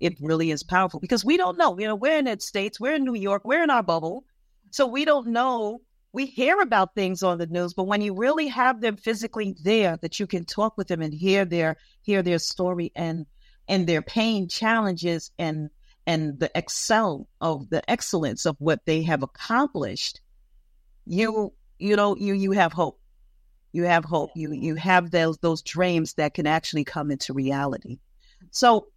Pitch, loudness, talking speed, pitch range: 185 Hz, -24 LUFS, 195 wpm, 160-220 Hz